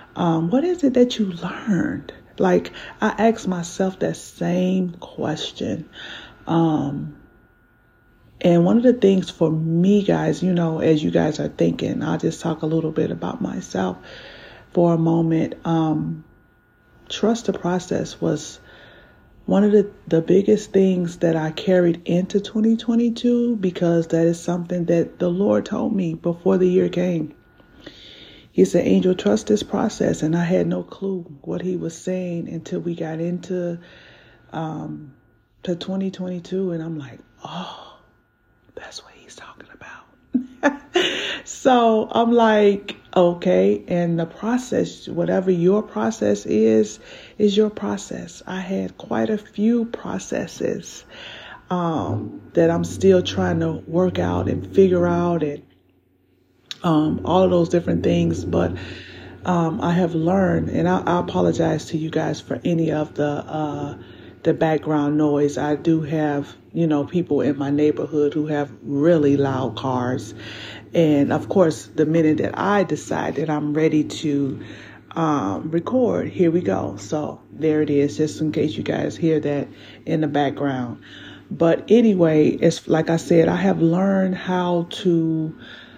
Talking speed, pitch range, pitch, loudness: 150 wpm, 145-185 Hz, 165 Hz, -21 LUFS